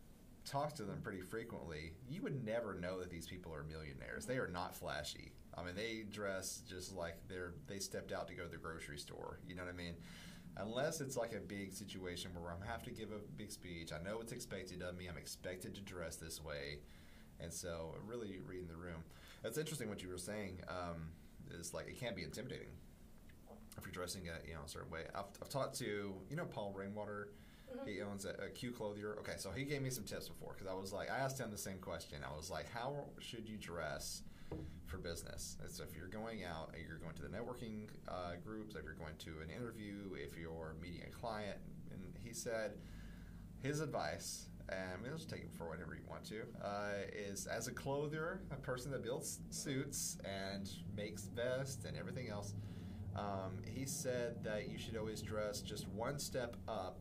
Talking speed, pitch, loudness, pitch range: 215 wpm, 95 Hz, -47 LUFS, 85-105 Hz